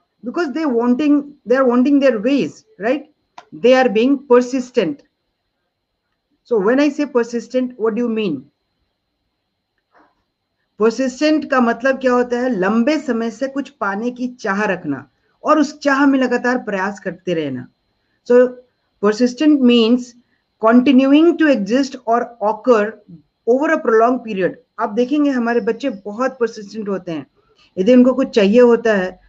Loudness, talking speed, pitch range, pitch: -16 LUFS, 125 wpm, 220-270 Hz, 245 Hz